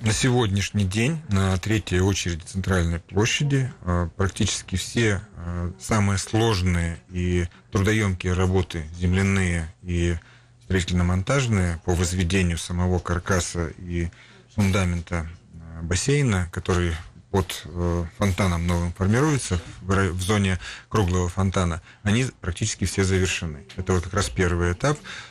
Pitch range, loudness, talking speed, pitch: 85-105 Hz, -24 LUFS, 105 wpm, 95 Hz